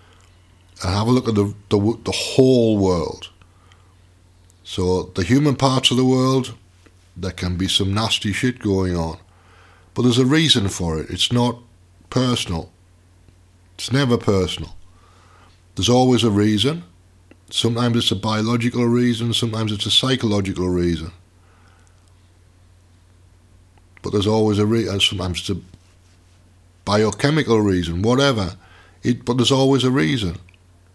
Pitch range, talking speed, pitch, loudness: 90-115 Hz, 130 wpm, 95 Hz, -19 LUFS